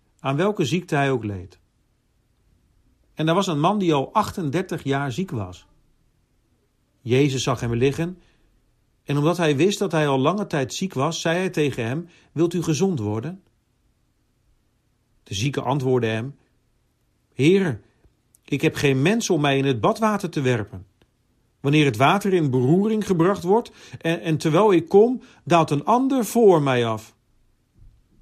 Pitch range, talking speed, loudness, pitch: 120-175 Hz, 155 wpm, -21 LUFS, 140 Hz